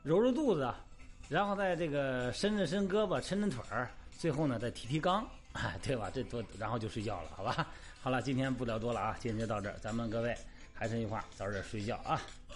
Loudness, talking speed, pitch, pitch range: -36 LUFS, 315 characters per minute, 120 Hz, 110-155 Hz